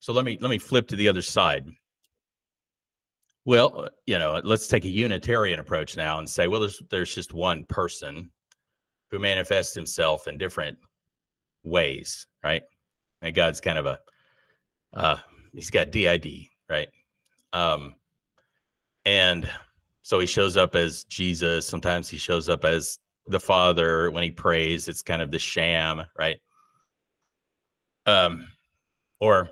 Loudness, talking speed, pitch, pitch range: -25 LUFS, 140 wpm, 90 Hz, 85-105 Hz